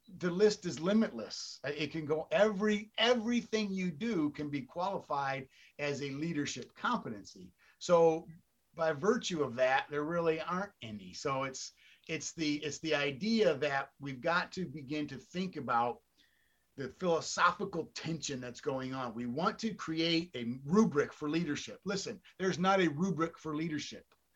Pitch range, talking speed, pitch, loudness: 145-190 Hz, 155 wpm, 160 Hz, -34 LUFS